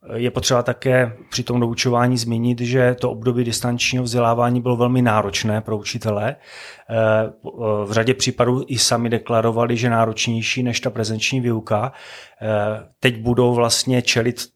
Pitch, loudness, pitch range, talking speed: 120 Hz, -19 LUFS, 115-125 Hz, 135 wpm